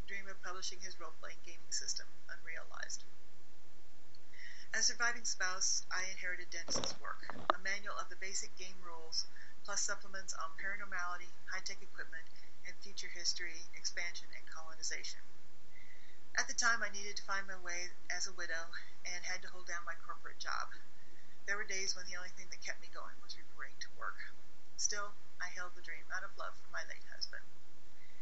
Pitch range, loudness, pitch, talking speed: 180-200 Hz, -41 LUFS, 185 Hz, 170 wpm